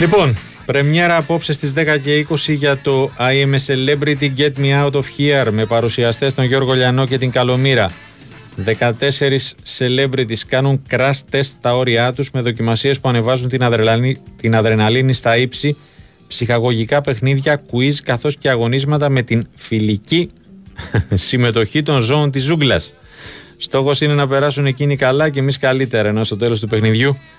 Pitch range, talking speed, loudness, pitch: 120-145 Hz, 155 wpm, -15 LUFS, 135 Hz